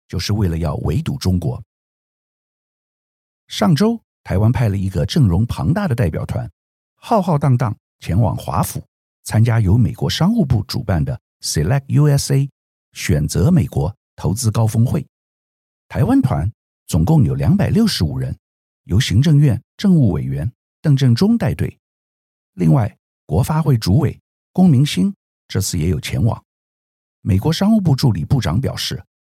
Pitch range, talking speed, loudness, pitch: 95-150 Hz, 235 characters per minute, -17 LUFS, 125 Hz